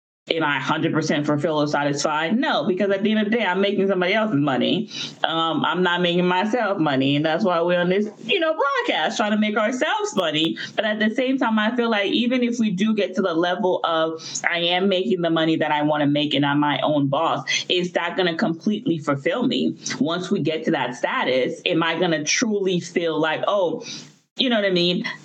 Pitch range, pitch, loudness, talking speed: 155-215 Hz, 180 Hz, -21 LUFS, 235 wpm